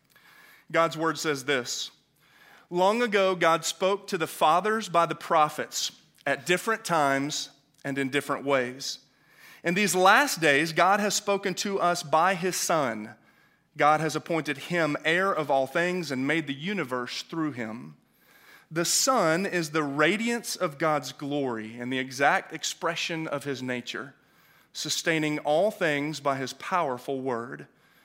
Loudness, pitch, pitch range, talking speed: -26 LUFS, 160 Hz, 140-180 Hz, 150 wpm